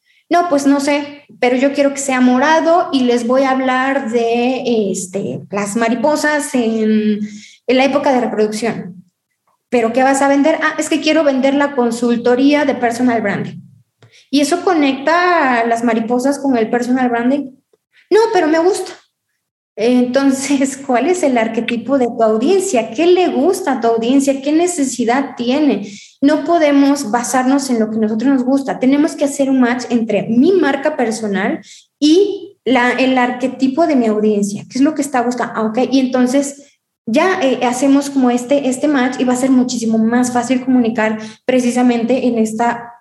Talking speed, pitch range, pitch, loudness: 175 wpm, 235-285 Hz, 255 Hz, -14 LUFS